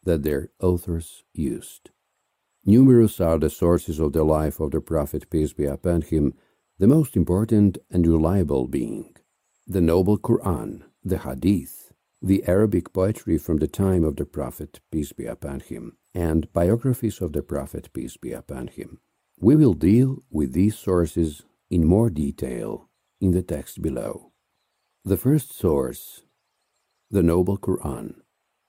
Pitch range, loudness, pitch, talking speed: 80-100 Hz, -22 LUFS, 85 Hz, 145 wpm